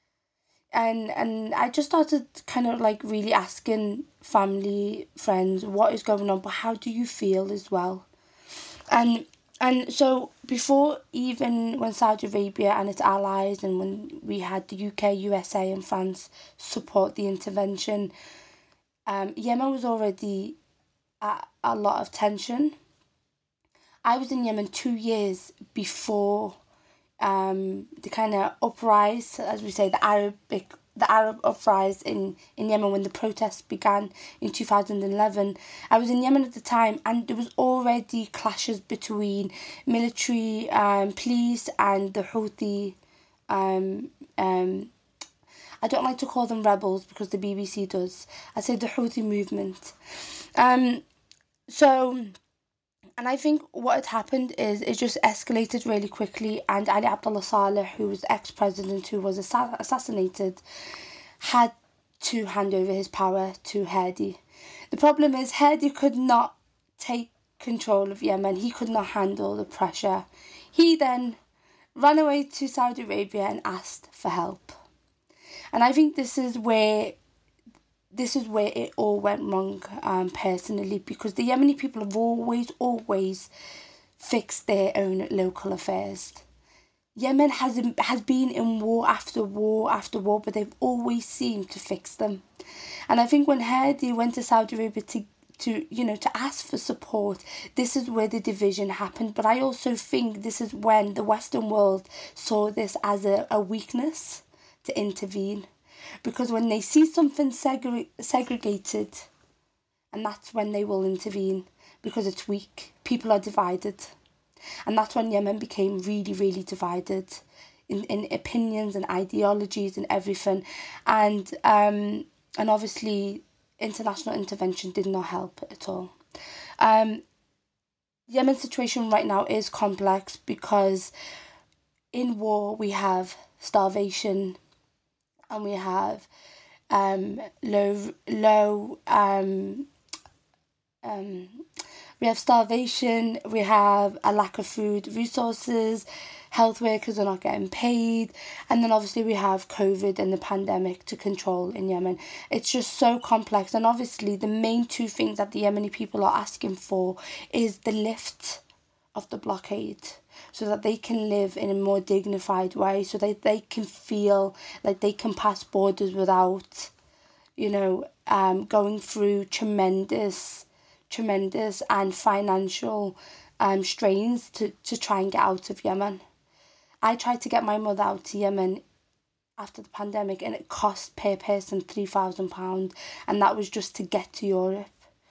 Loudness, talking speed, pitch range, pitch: -26 LUFS, 150 wpm, 195-240 Hz, 210 Hz